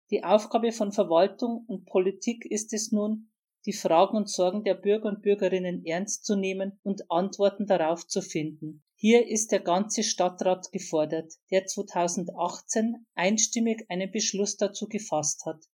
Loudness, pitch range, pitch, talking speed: -27 LUFS, 180-215 Hz, 200 Hz, 150 wpm